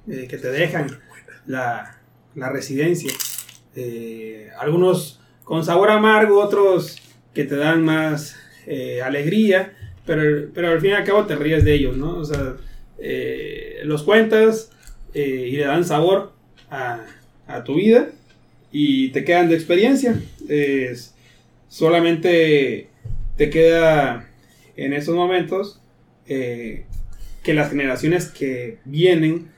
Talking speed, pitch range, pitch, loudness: 130 wpm, 135-185 Hz, 160 Hz, -19 LUFS